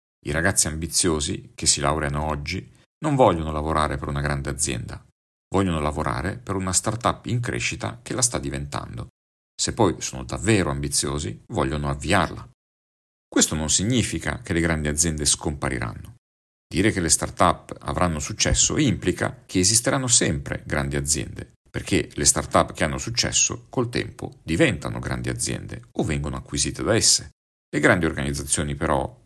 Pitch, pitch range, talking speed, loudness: 75 Hz, 70-95 Hz, 150 wpm, -22 LUFS